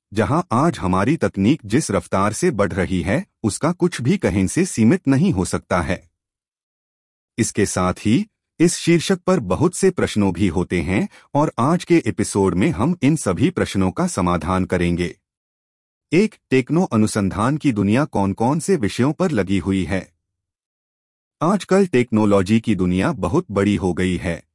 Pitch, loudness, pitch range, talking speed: 100 Hz, -19 LUFS, 90-145 Hz, 160 wpm